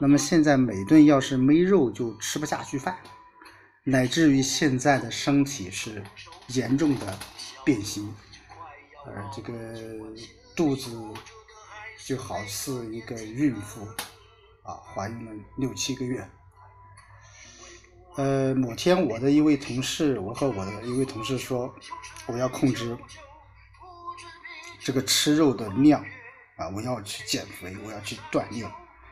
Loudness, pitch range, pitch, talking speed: -25 LUFS, 105-145 Hz, 125 Hz, 185 characters per minute